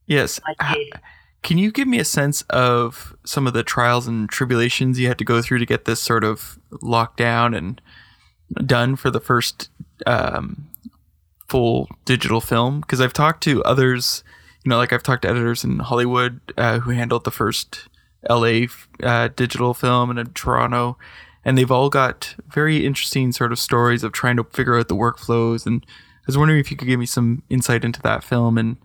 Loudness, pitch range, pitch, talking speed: -19 LUFS, 115-130 Hz, 120 Hz, 190 wpm